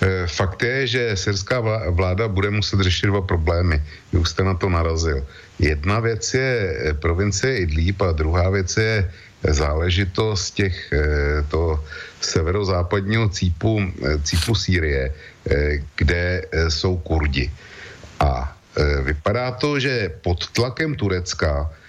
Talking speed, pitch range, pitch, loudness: 110 wpm, 80-105 Hz, 95 Hz, -21 LUFS